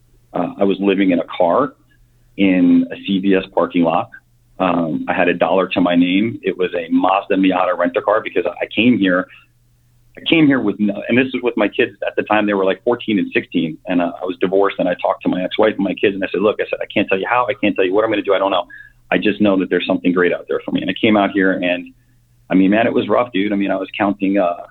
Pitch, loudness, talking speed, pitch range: 100 Hz, -17 LUFS, 285 wpm, 95-120 Hz